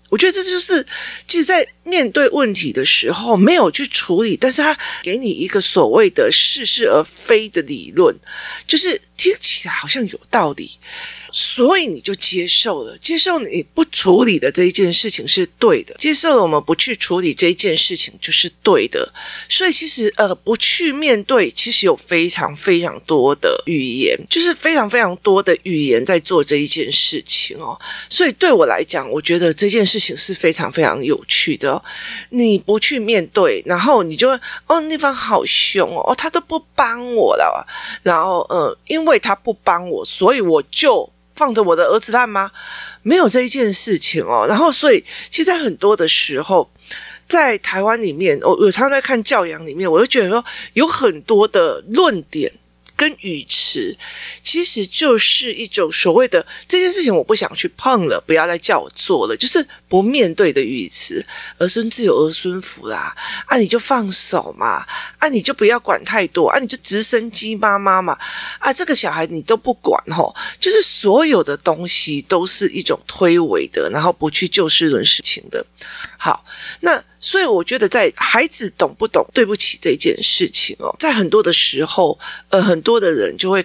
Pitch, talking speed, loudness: 275 Hz, 270 characters per minute, -14 LUFS